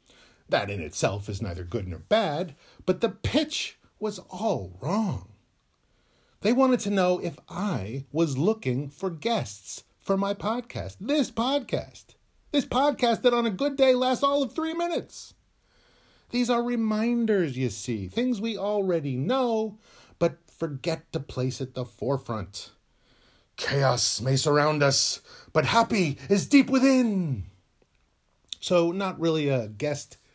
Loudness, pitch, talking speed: -26 LUFS, 185 Hz, 140 wpm